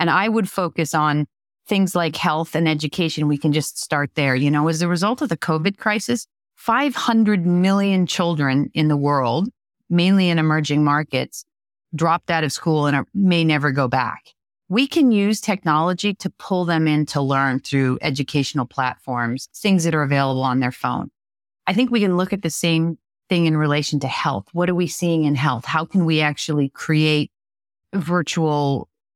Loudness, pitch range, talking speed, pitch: -20 LUFS, 145-185 Hz, 185 wpm, 160 Hz